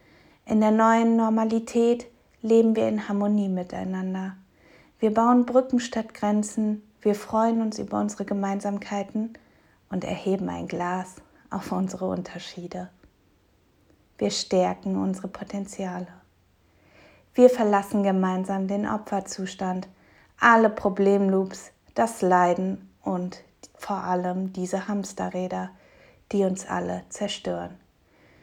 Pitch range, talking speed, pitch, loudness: 180-215 Hz, 105 wpm, 195 Hz, -25 LUFS